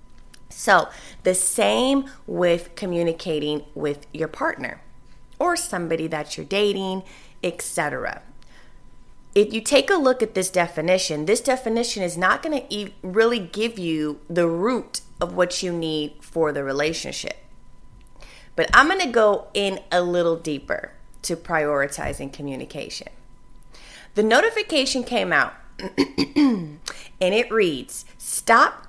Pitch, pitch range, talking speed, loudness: 180 Hz, 160-225 Hz, 125 wpm, -22 LUFS